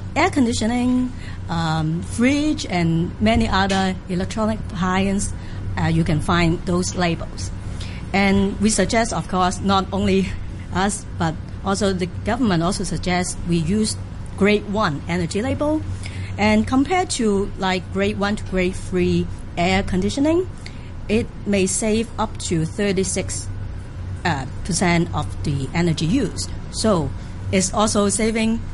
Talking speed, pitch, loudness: 125 wpm, 170 Hz, -21 LUFS